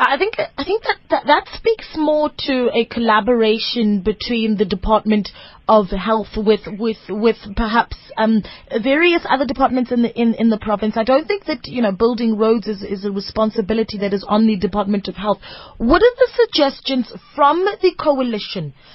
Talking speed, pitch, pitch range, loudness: 180 wpm, 225 Hz, 215-280 Hz, -18 LUFS